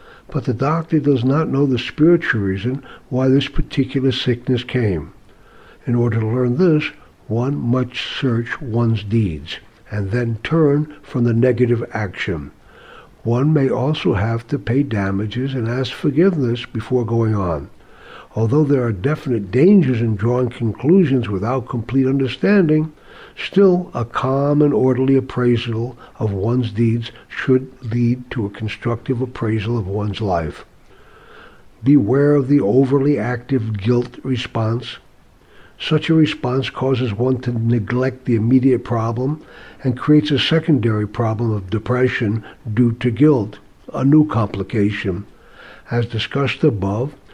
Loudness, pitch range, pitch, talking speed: -18 LUFS, 115-135 Hz, 125 Hz, 135 wpm